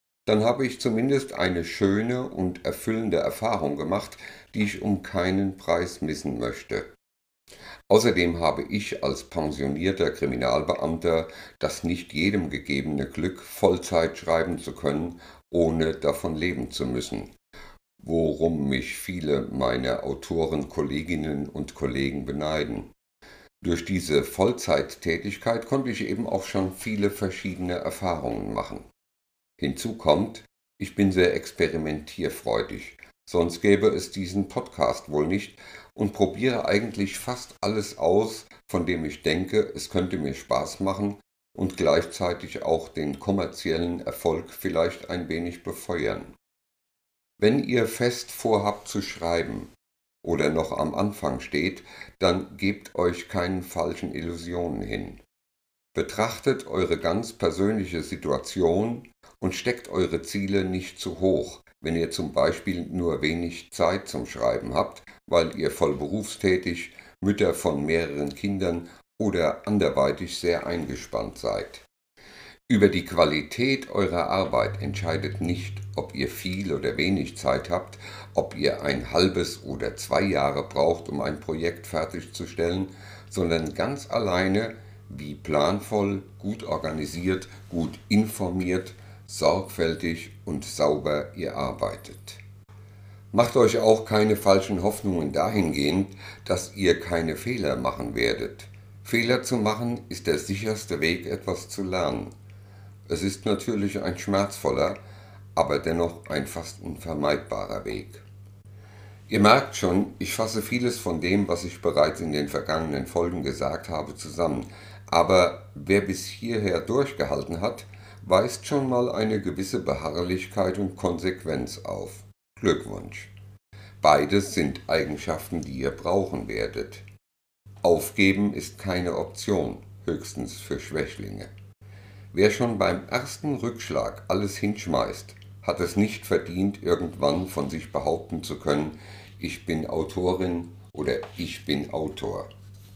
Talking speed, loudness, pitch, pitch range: 125 wpm, -26 LUFS, 95 Hz, 80-100 Hz